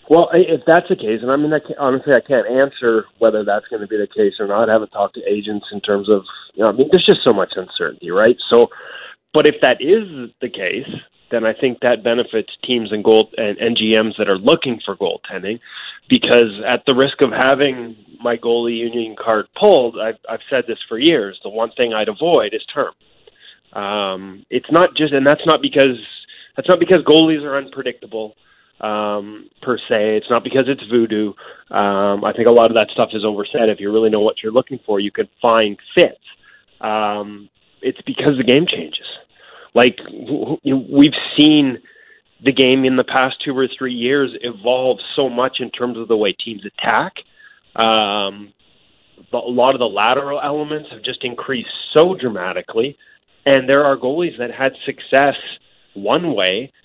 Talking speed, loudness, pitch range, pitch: 195 wpm, -16 LUFS, 110-150 Hz, 125 Hz